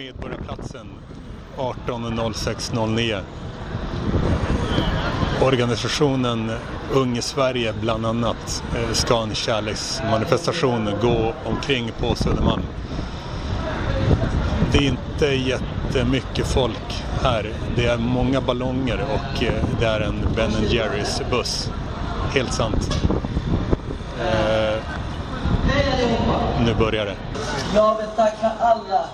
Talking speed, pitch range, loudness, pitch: 75 wpm, 110-130 Hz, -22 LUFS, 115 Hz